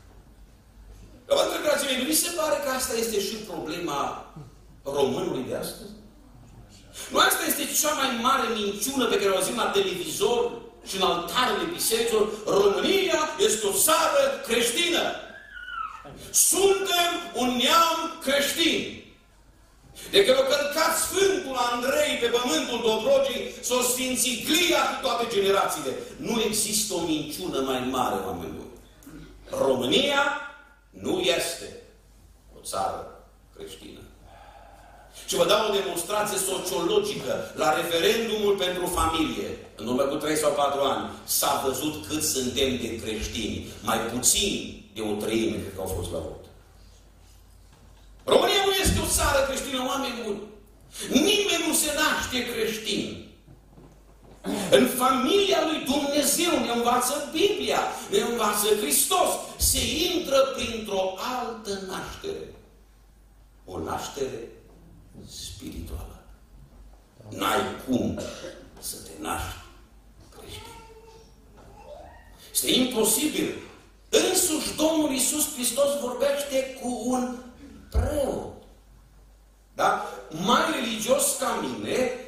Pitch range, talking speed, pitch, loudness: 190-310 Hz, 110 wpm, 250 Hz, -24 LUFS